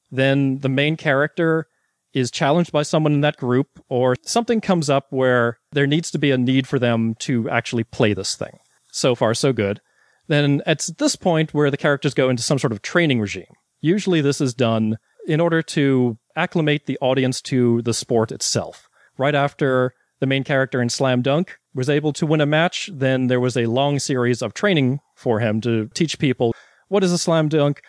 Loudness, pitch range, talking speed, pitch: -20 LUFS, 125-155 Hz, 200 wpm, 140 Hz